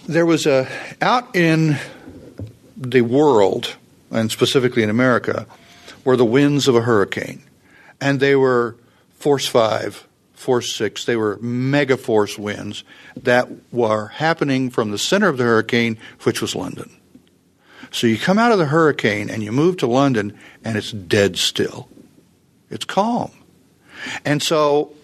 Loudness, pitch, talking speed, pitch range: -18 LUFS, 130 Hz, 145 wpm, 115-150 Hz